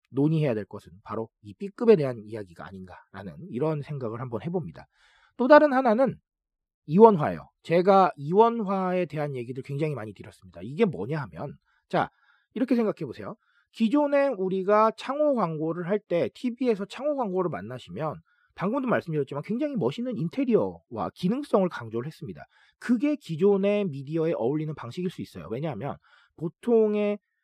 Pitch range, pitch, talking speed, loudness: 140-225 Hz, 180 Hz, 365 characters per minute, -26 LUFS